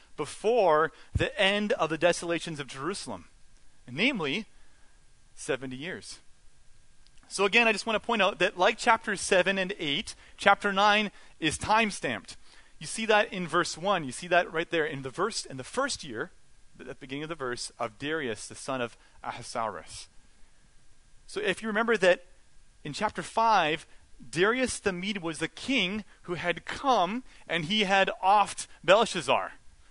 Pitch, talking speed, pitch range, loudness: 185 Hz, 165 wpm, 160-210 Hz, -28 LUFS